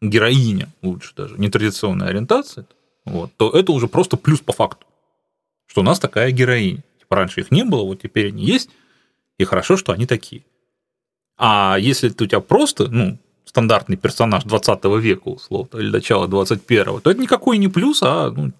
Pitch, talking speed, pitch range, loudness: 120 Hz, 175 wpm, 105-145 Hz, -17 LUFS